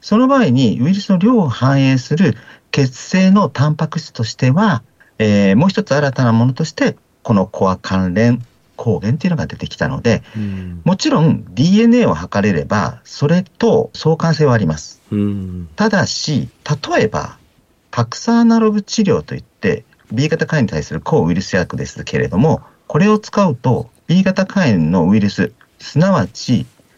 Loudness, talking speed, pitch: -15 LUFS, 315 characters per minute, 145 Hz